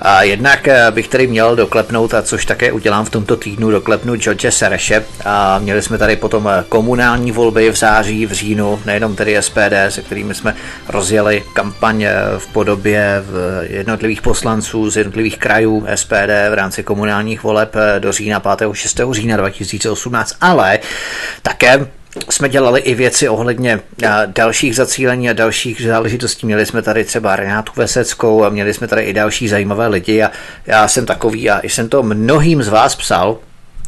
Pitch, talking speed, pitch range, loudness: 110 Hz, 165 wpm, 105-115 Hz, -13 LUFS